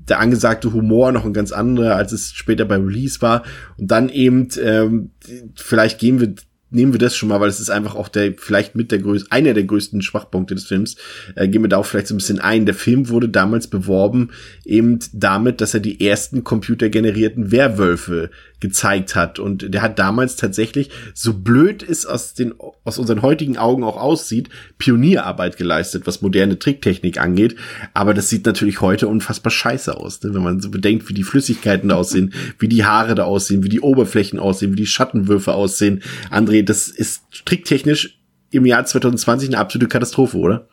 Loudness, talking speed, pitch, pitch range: -16 LUFS, 190 wpm, 110 Hz, 100-120 Hz